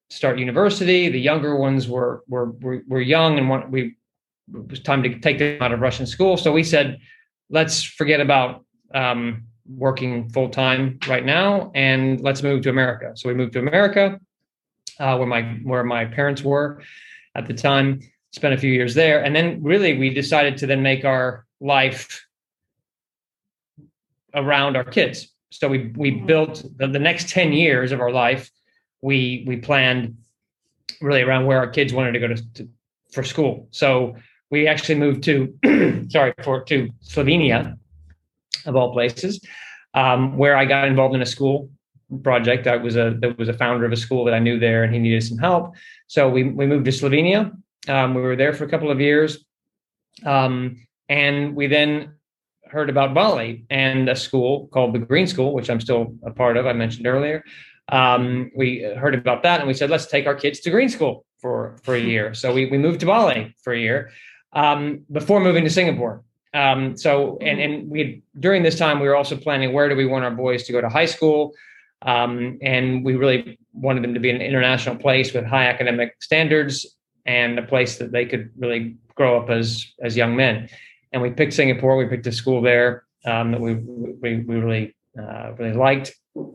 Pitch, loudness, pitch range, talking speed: 130 Hz, -19 LUFS, 125-145 Hz, 195 wpm